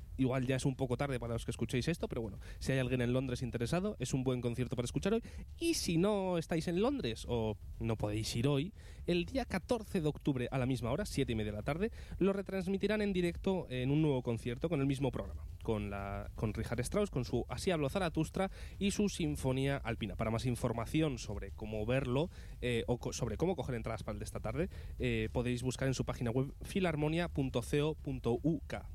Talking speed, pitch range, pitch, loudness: 220 wpm, 115-160 Hz, 130 Hz, -36 LUFS